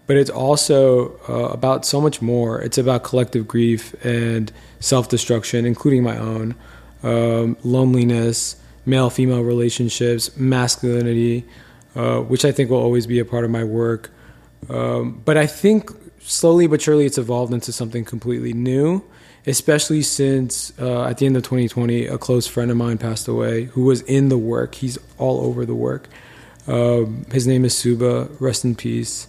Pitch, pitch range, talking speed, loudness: 120 Hz, 115-130 Hz, 170 wpm, -19 LUFS